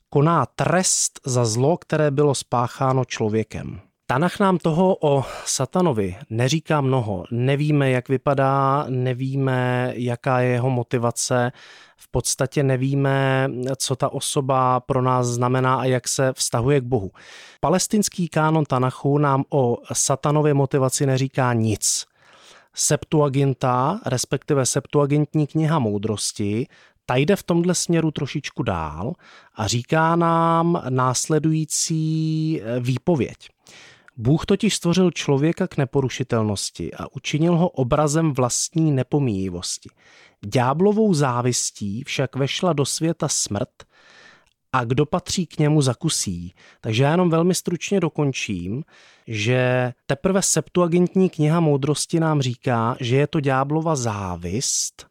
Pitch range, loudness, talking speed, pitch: 125-160 Hz, -21 LUFS, 115 wpm, 140 Hz